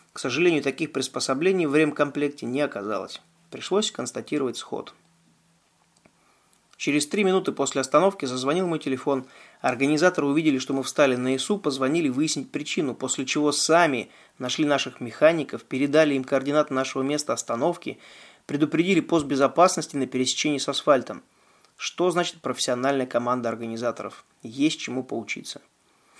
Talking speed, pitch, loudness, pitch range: 130 wpm, 140 Hz, -24 LUFS, 130-160 Hz